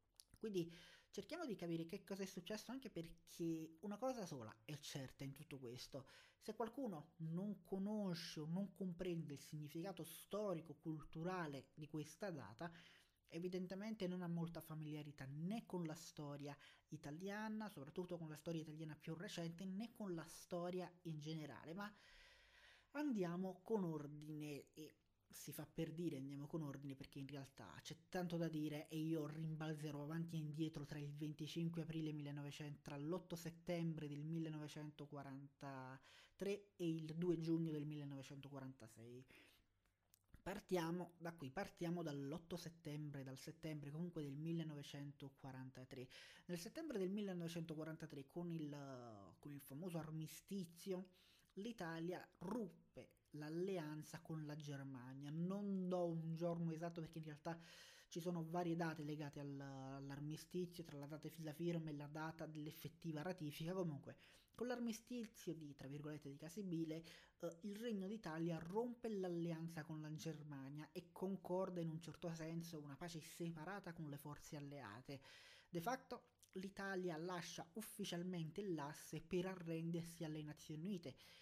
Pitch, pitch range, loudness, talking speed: 160 Hz, 150-180 Hz, -50 LUFS, 140 wpm